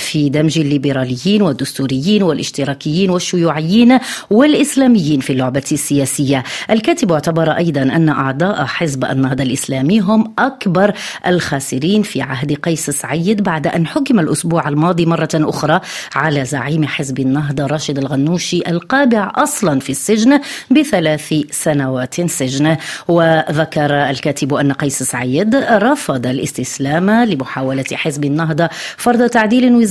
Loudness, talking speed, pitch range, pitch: -14 LUFS, 115 wpm, 140-200 Hz, 155 Hz